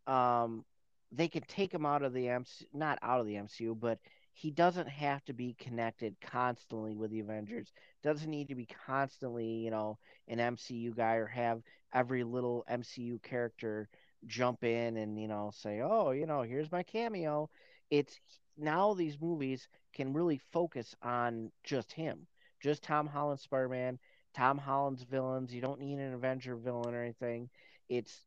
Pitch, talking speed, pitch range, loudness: 125 Hz, 170 wpm, 115-145 Hz, -37 LUFS